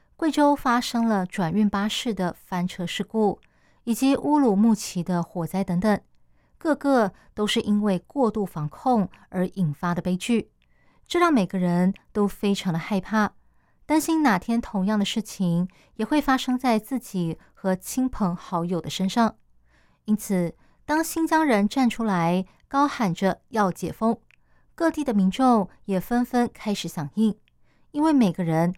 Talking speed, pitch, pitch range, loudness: 225 characters per minute, 210 Hz, 180-245 Hz, -24 LUFS